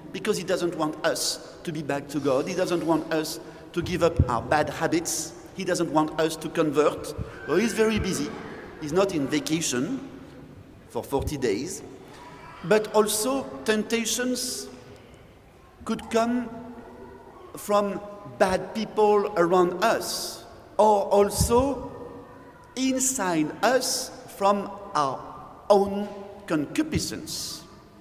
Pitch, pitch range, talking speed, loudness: 190 Hz, 160-215 Hz, 120 wpm, -25 LUFS